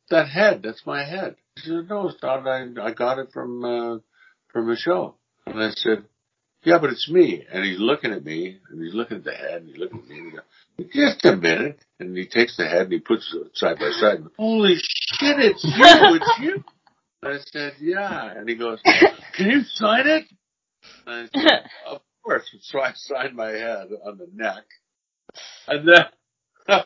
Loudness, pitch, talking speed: -19 LUFS, 140 Hz, 210 wpm